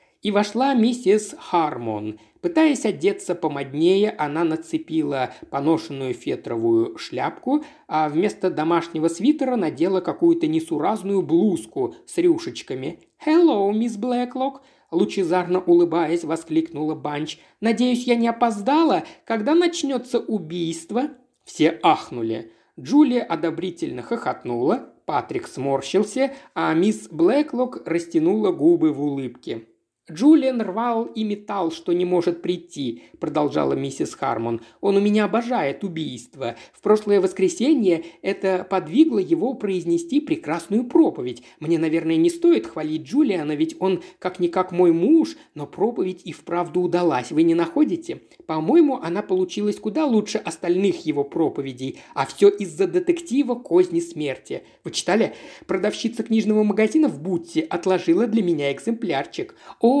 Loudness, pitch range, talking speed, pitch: -22 LUFS, 165-275 Hz, 120 wpm, 200 Hz